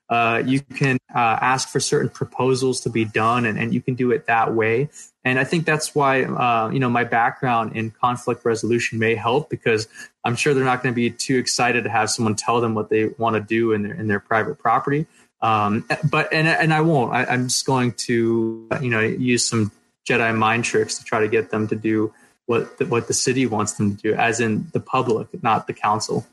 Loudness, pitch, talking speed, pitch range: -20 LUFS, 120 Hz, 230 wpm, 110-130 Hz